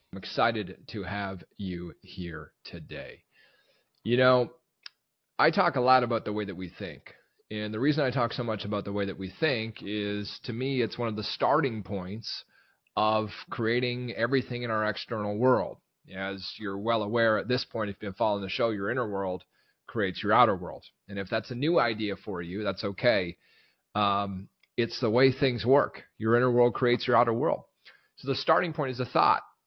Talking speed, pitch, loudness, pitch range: 200 wpm, 110 Hz, -28 LUFS, 100-125 Hz